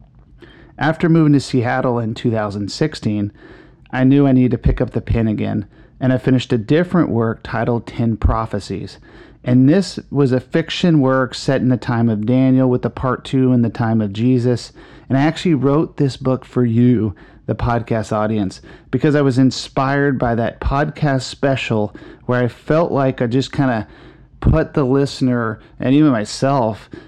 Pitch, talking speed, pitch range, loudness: 130 Hz, 175 wpm, 115-140 Hz, -17 LUFS